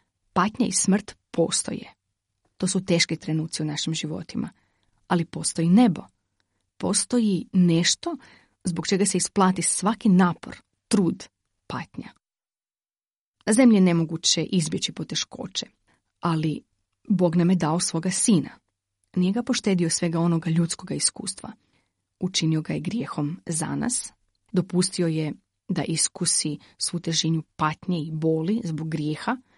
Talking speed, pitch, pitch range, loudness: 120 wpm, 170 Hz, 155-190 Hz, -24 LUFS